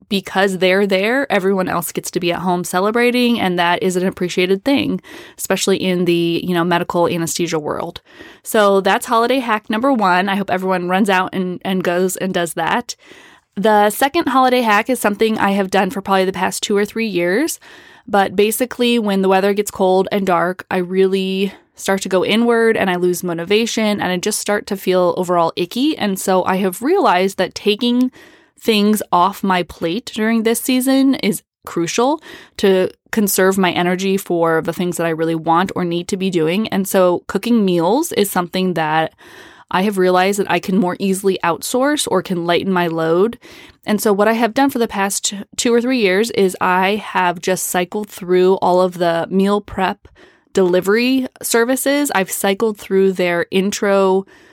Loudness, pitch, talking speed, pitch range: -16 LUFS, 195 Hz, 185 wpm, 180-220 Hz